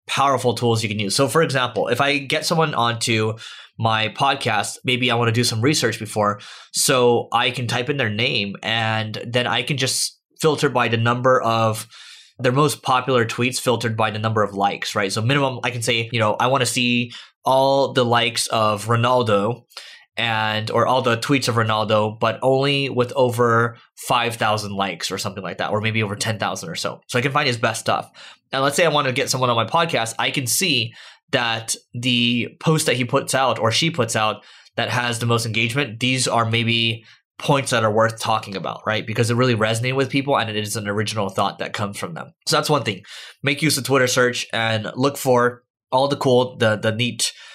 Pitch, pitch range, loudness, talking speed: 120 Hz, 110-130 Hz, -20 LUFS, 215 wpm